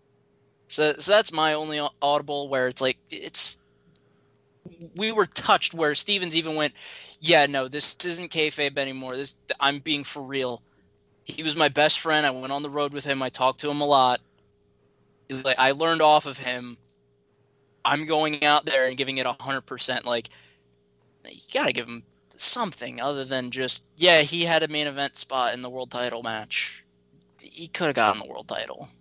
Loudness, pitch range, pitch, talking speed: -23 LUFS, 130-155 Hz, 140 Hz, 180 wpm